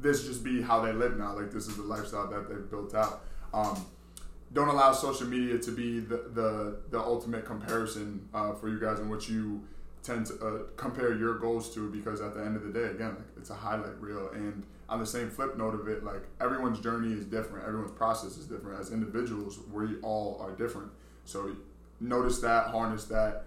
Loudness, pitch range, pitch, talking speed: -33 LUFS, 105-115 Hz, 110 Hz, 210 wpm